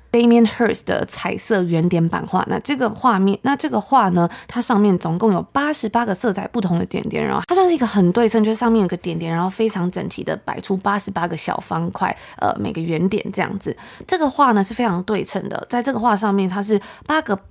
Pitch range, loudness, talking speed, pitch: 185-235 Hz, -19 LUFS, 370 characters per minute, 210 Hz